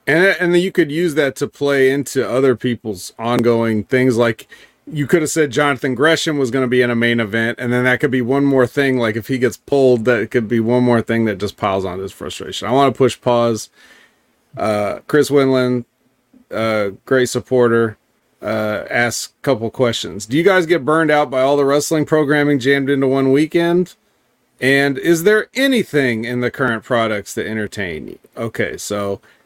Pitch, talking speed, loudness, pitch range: 130 Hz, 200 wpm, -16 LUFS, 115-145 Hz